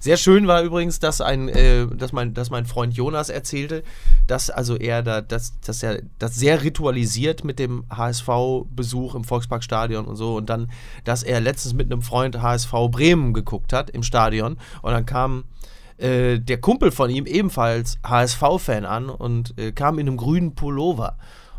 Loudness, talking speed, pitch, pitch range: -21 LUFS, 175 wpm, 125 Hz, 115-135 Hz